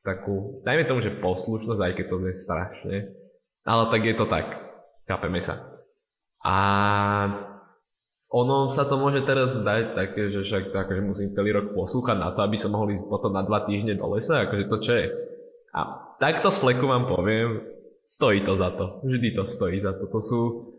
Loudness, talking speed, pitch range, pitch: -25 LUFS, 190 wpm, 100-120 Hz, 105 Hz